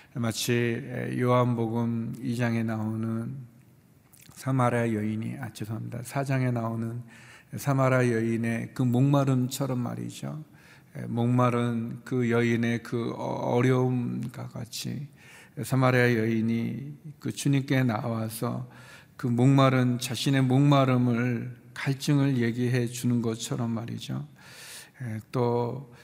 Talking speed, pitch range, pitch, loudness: 225 characters per minute, 115-130 Hz, 120 Hz, -27 LUFS